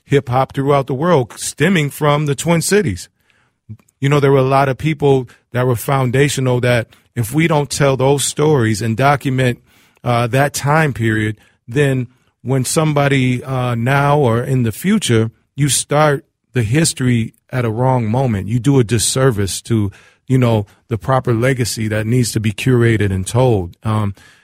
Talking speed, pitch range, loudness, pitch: 170 wpm, 115-140 Hz, -16 LUFS, 130 Hz